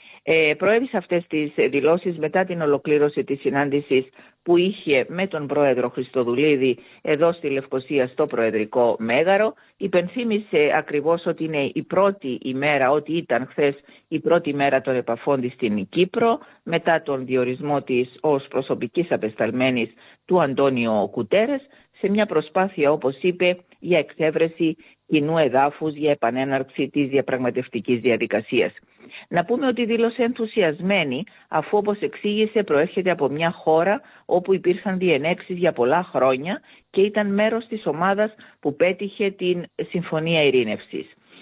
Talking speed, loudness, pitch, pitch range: 130 wpm, -22 LUFS, 160 Hz, 135-190 Hz